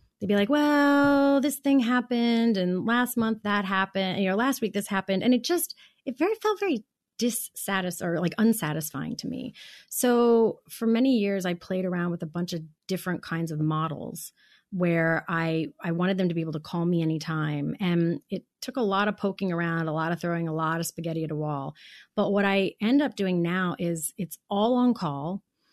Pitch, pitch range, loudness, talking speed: 190 Hz, 170-235 Hz, -26 LUFS, 210 wpm